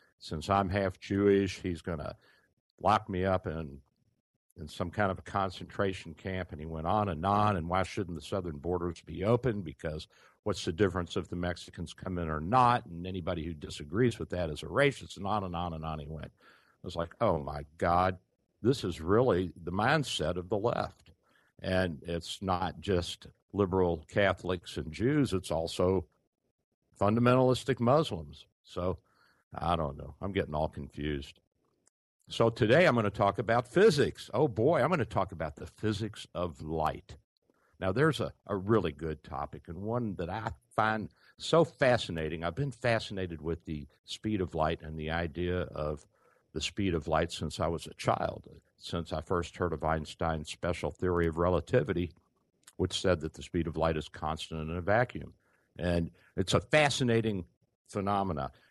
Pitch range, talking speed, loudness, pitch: 80-105 Hz, 180 wpm, -32 LUFS, 90 Hz